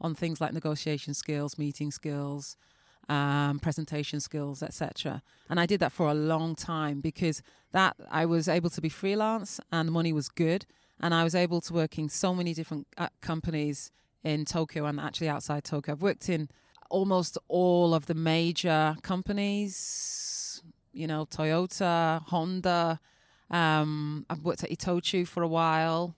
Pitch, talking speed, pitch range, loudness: 160 Hz, 160 wpm, 150-175 Hz, -30 LUFS